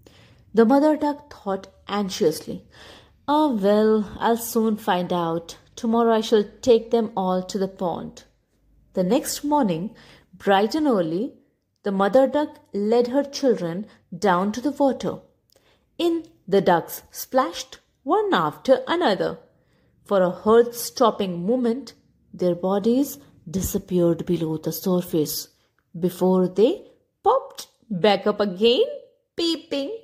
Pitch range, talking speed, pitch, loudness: 185-270 Hz, 120 wpm, 220 Hz, -22 LUFS